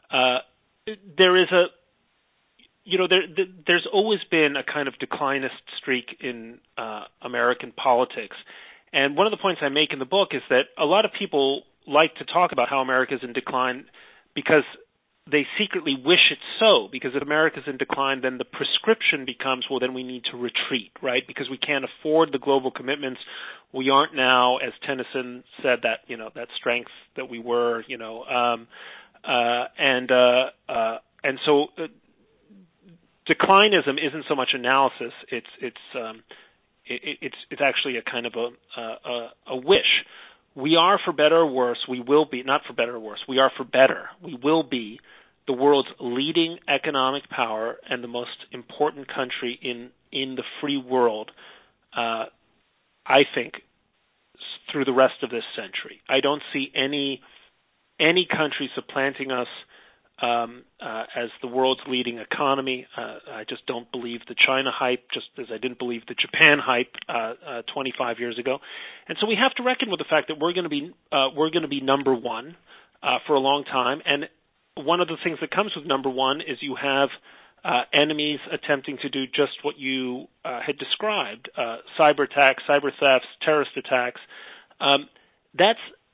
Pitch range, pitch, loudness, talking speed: 125-155 Hz, 135 Hz, -23 LUFS, 180 wpm